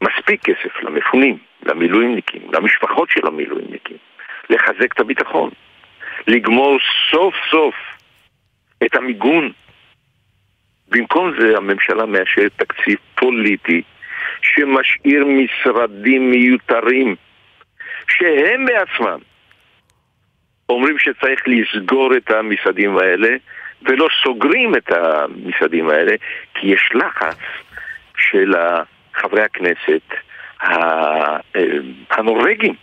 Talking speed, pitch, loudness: 85 wpm, 130 Hz, -15 LUFS